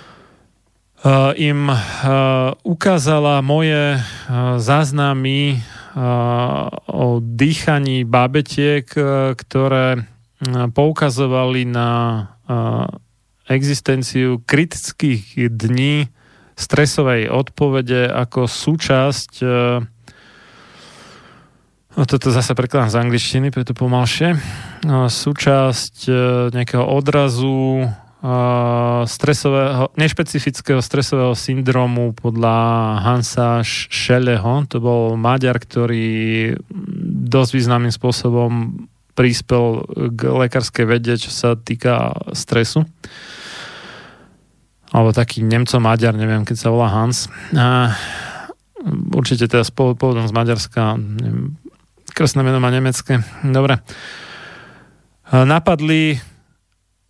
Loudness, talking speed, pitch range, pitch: -17 LUFS, 85 wpm, 120-140 Hz, 125 Hz